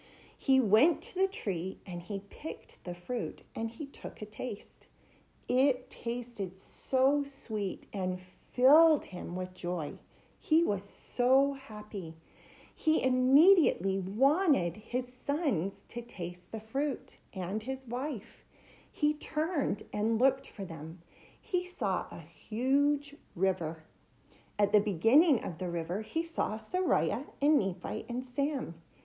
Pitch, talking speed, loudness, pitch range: 245 Hz, 130 wpm, -31 LUFS, 195-285 Hz